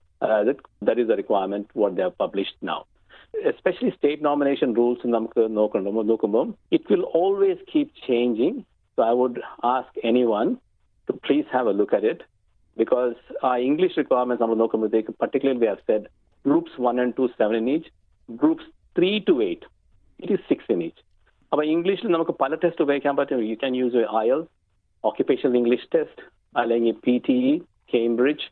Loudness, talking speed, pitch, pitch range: -23 LUFS, 145 wpm, 130 Hz, 120-185 Hz